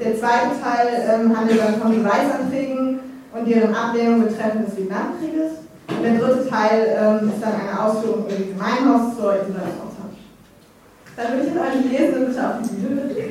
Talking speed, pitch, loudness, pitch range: 165 wpm, 225 Hz, -20 LUFS, 215-255 Hz